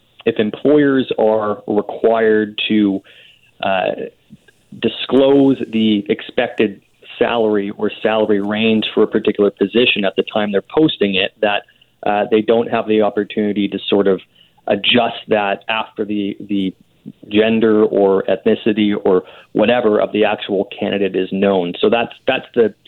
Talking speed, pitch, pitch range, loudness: 140 wpm, 105 Hz, 100-110 Hz, -16 LUFS